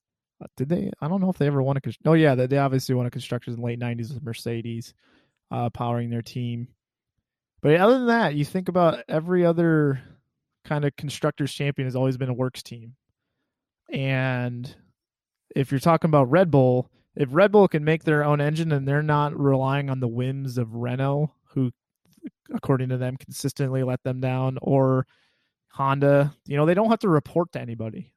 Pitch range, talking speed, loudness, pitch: 125-150 Hz, 190 wpm, -23 LUFS, 135 Hz